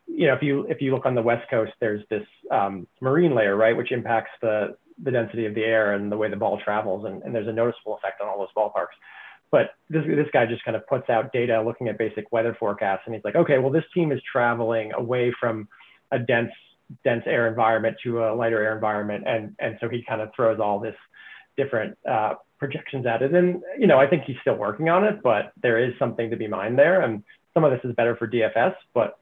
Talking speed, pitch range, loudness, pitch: 240 wpm, 110-135 Hz, -24 LUFS, 115 Hz